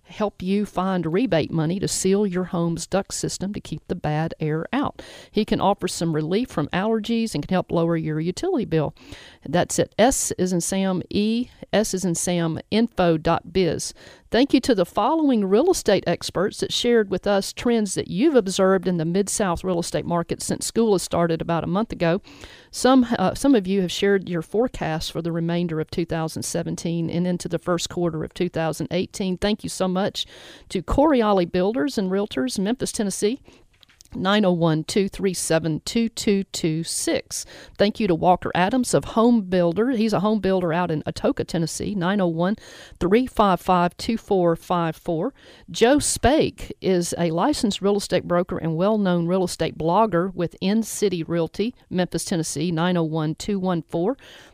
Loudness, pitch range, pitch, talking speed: -22 LUFS, 170-210 Hz, 185 Hz, 155 wpm